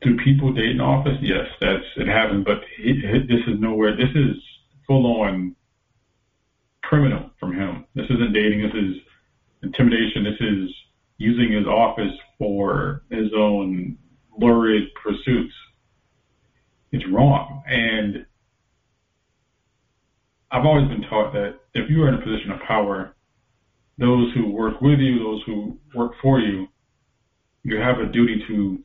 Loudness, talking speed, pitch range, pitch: -21 LUFS, 145 wpm, 105-125 Hz, 115 Hz